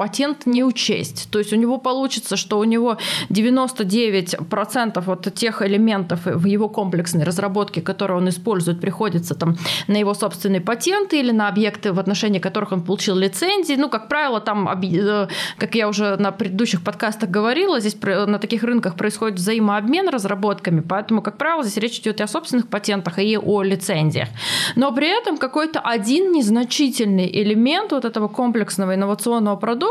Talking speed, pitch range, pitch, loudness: 160 wpm, 195-235 Hz, 210 Hz, -20 LUFS